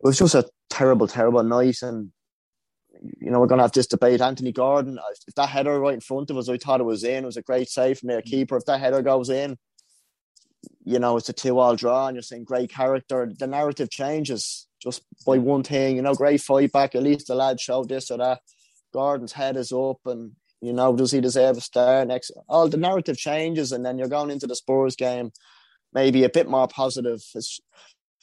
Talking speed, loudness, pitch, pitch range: 225 wpm, -22 LUFS, 130 Hz, 125-135 Hz